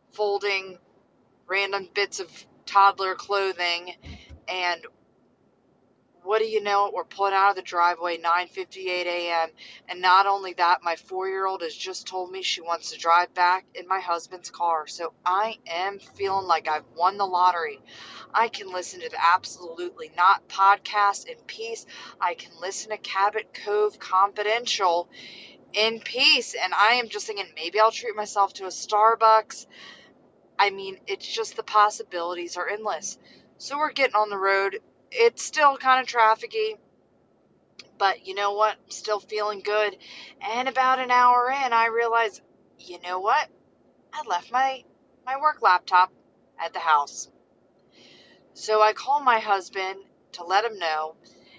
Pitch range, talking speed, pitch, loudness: 180-235 Hz, 155 wpm, 200 Hz, -24 LUFS